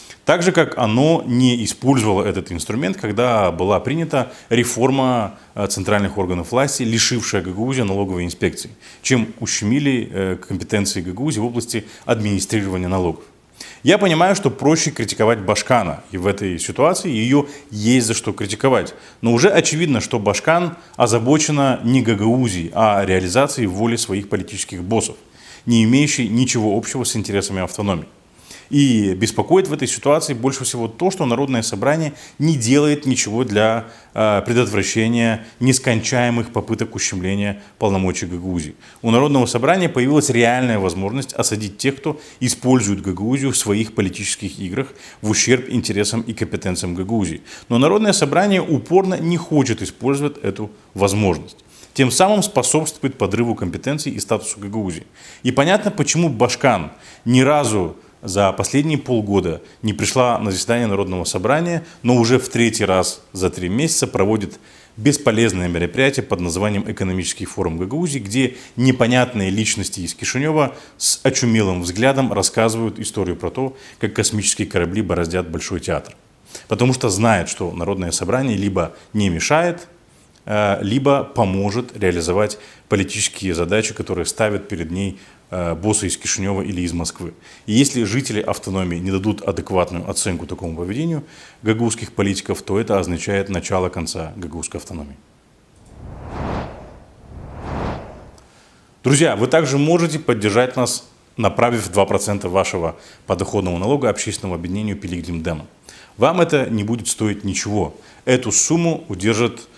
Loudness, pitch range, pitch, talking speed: -18 LUFS, 100-130 Hz, 110 Hz, 130 wpm